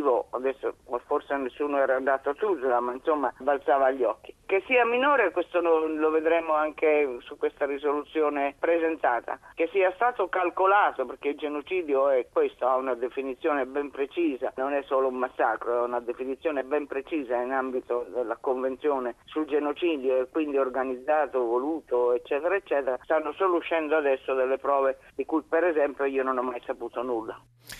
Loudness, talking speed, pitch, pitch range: -27 LUFS, 160 wpm, 140 Hz, 130-160 Hz